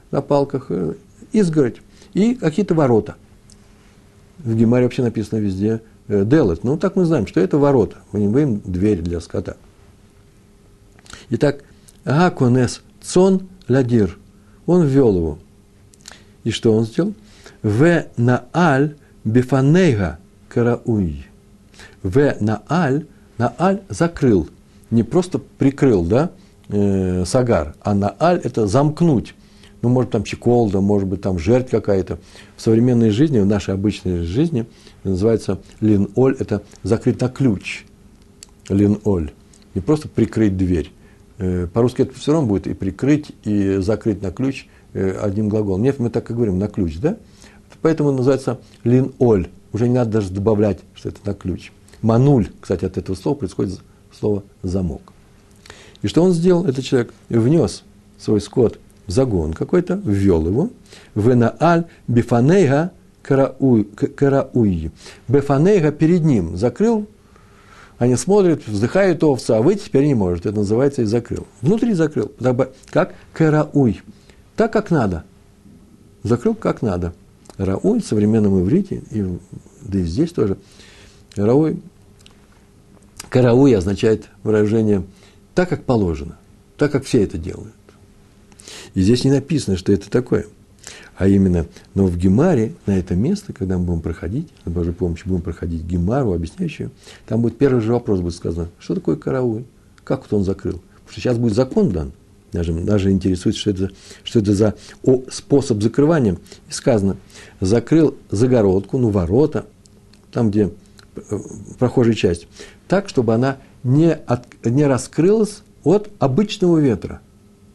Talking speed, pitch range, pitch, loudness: 140 wpm, 100-135 Hz, 110 Hz, -18 LUFS